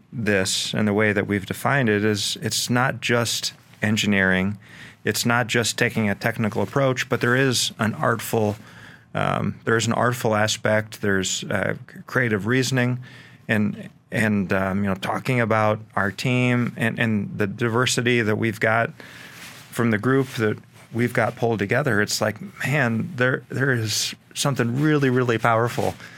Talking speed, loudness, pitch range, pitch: 155 wpm, -22 LUFS, 105-125 Hz, 115 Hz